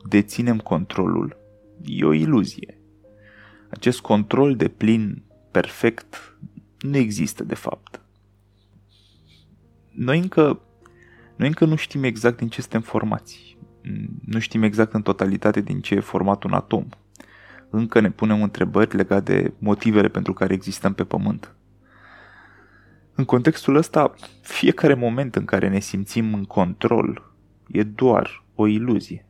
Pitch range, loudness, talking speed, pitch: 100-120 Hz, -21 LUFS, 130 wpm, 105 Hz